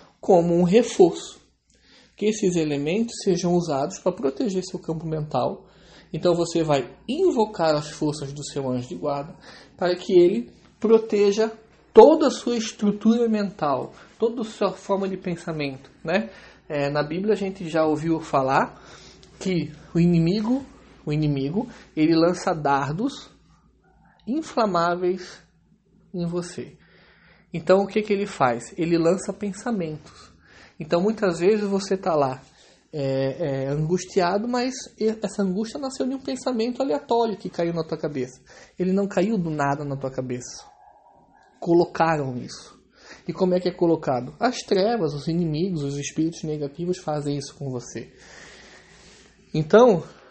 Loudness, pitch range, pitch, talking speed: -23 LUFS, 155-205 Hz, 180 Hz, 140 wpm